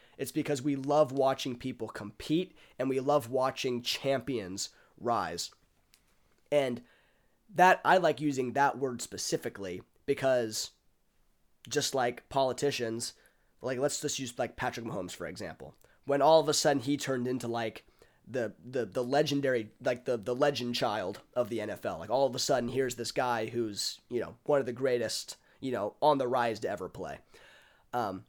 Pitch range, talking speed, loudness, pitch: 120-145 Hz, 170 wpm, -31 LUFS, 130 Hz